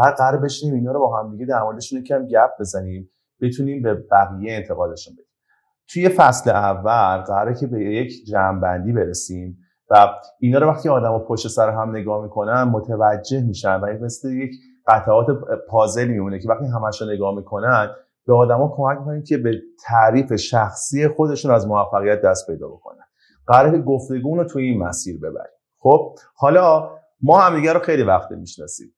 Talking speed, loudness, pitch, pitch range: 165 wpm, -18 LUFS, 115 Hz, 105-140 Hz